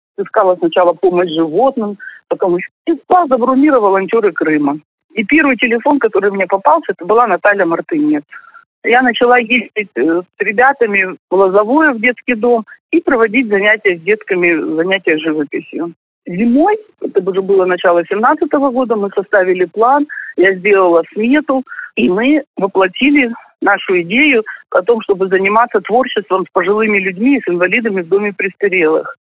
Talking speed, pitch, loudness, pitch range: 140 wpm, 220 Hz, -13 LUFS, 190-270 Hz